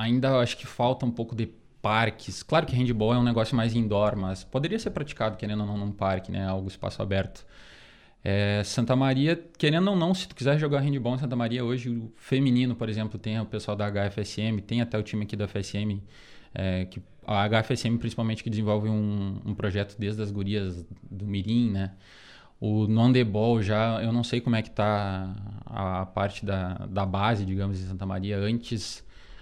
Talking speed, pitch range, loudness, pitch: 200 wpm, 100-120 Hz, -28 LUFS, 110 Hz